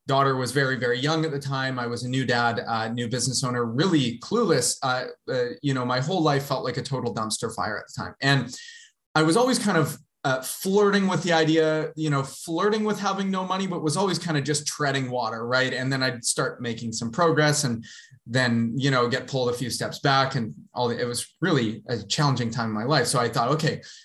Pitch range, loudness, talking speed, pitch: 125-160 Hz, -24 LUFS, 235 wpm, 135 Hz